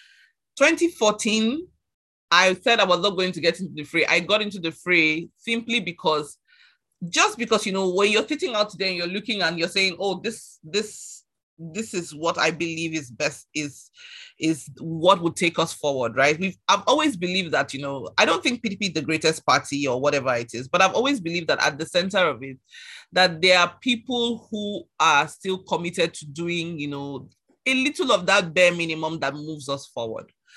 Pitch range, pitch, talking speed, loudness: 155-210 Hz, 175 Hz, 200 wpm, -22 LUFS